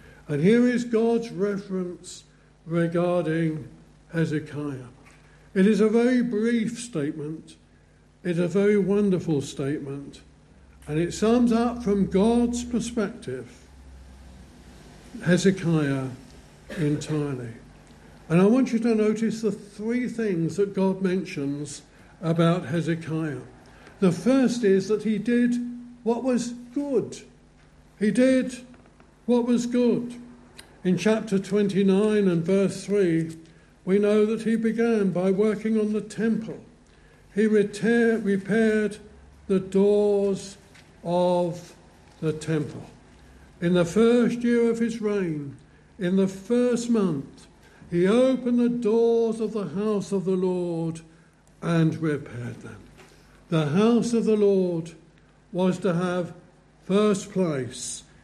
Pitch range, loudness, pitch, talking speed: 160-220 Hz, -24 LUFS, 195 Hz, 115 wpm